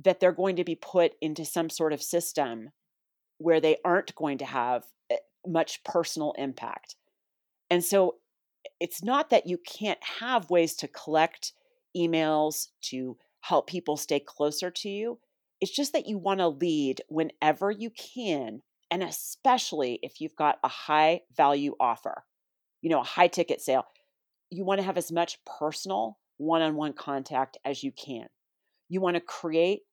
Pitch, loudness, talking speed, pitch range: 170 Hz, -28 LUFS, 165 wpm, 150-195 Hz